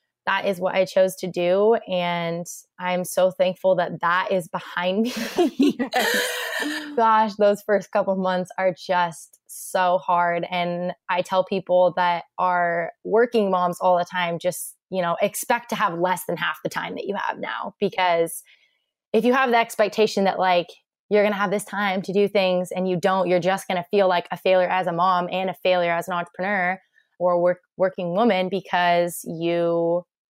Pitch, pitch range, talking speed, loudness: 185 Hz, 180-200 Hz, 190 wpm, -22 LUFS